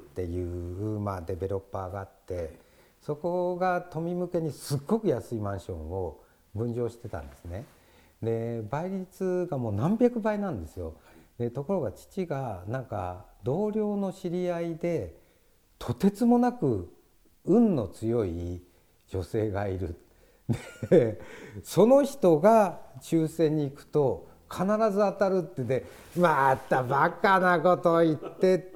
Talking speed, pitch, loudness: 230 characters per minute, 140 Hz, -28 LUFS